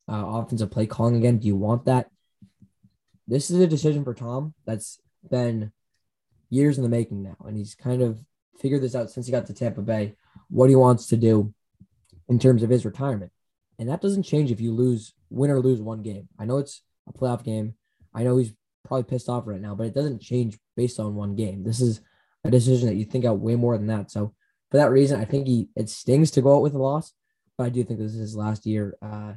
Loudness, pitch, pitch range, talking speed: -24 LUFS, 115 Hz, 105-130 Hz, 235 wpm